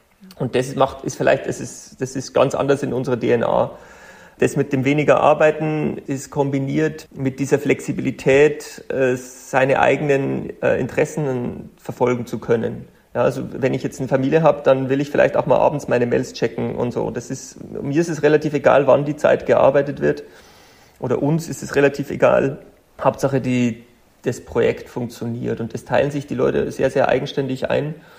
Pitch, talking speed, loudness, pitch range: 135 Hz, 175 wpm, -19 LUFS, 125-145 Hz